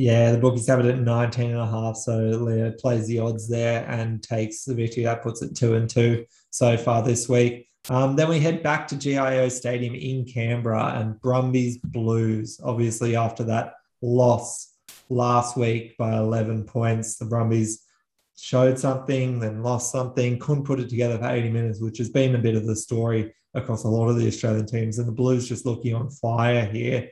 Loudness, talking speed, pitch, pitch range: -24 LUFS, 195 wpm, 120 Hz, 115-125 Hz